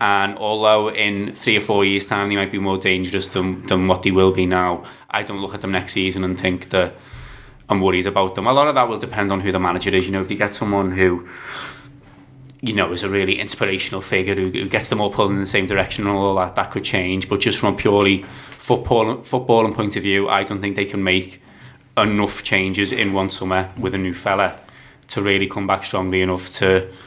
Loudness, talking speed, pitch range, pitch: -19 LUFS, 235 wpm, 95-100 Hz, 95 Hz